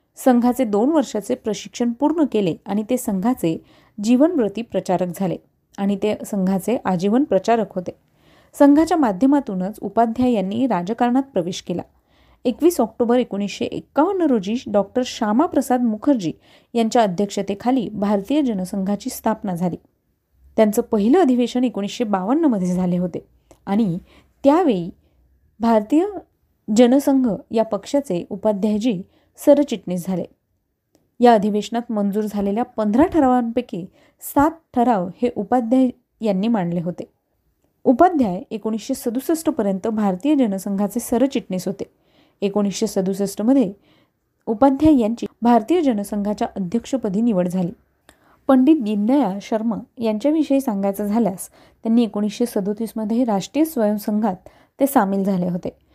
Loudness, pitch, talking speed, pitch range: -20 LUFS, 225 Hz, 110 wpm, 200-255 Hz